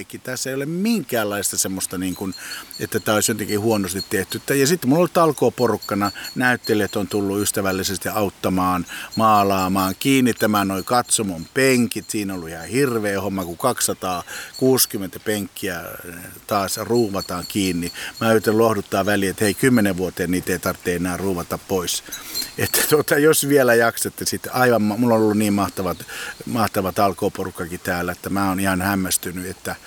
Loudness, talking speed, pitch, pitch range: -20 LUFS, 150 wpm, 100 Hz, 95-115 Hz